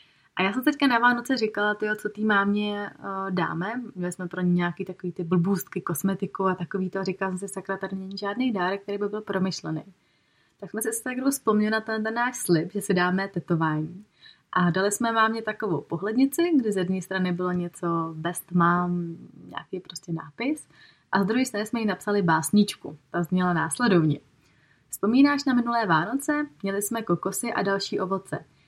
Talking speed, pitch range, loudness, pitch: 185 wpm, 175-220 Hz, -26 LUFS, 195 Hz